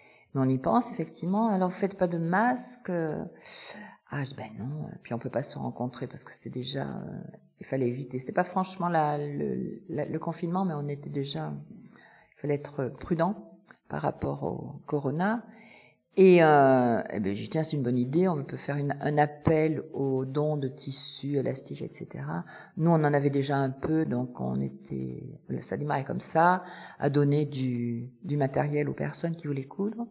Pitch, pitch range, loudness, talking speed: 145 Hz, 130-170 Hz, -29 LUFS, 185 wpm